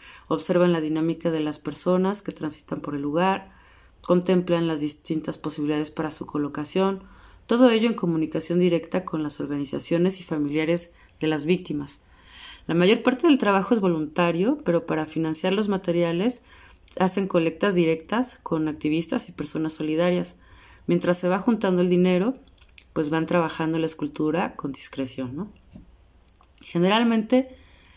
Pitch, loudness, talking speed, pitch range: 170 Hz, -24 LUFS, 140 wpm, 155-185 Hz